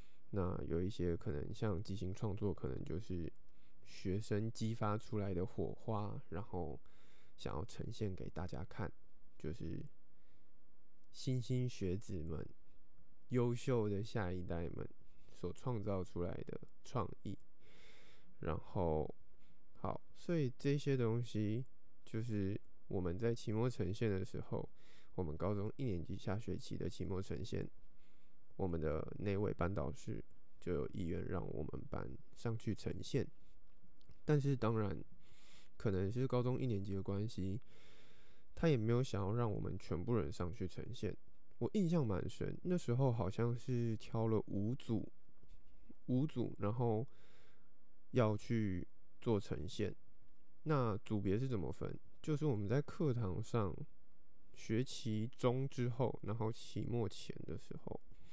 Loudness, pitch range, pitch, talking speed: -42 LUFS, 90-120 Hz, 105 Hz, 200 characters per minute